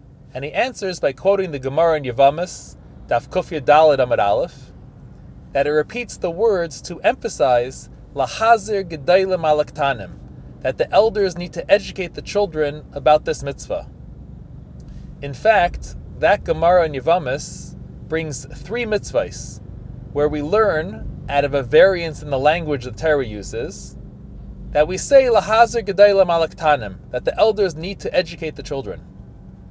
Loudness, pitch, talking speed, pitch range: -19 LUFS, 150 Hz, 135 wpm, 135-185 Hz